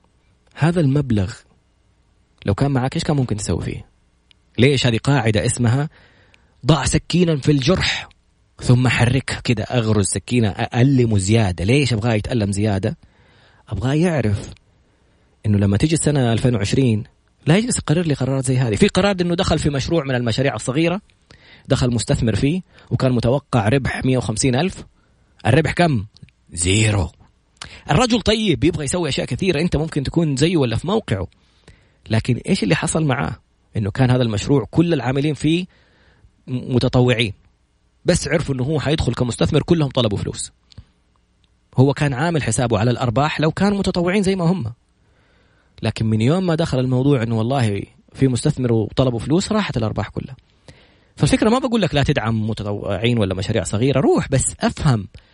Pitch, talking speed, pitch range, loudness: 125 Hz, 150 wpm, 110-150 Hz, -19 LUFS